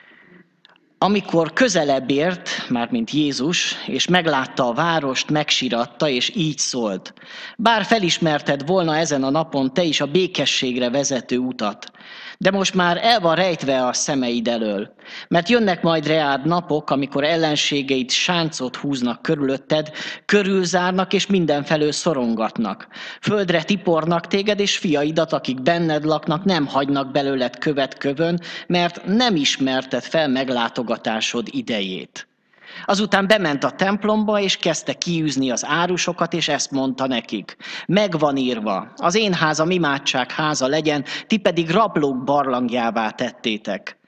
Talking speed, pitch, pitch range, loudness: 130 wpm, 155 Hz, 135-180 Hz, -20 LUFS